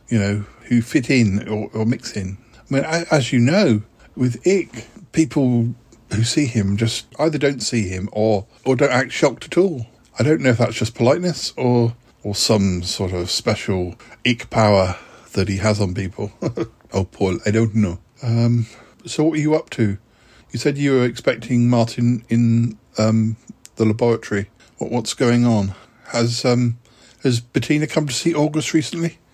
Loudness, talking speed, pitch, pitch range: -19 LUFS, 180 wpm, 115 Hz, 110-130 Hz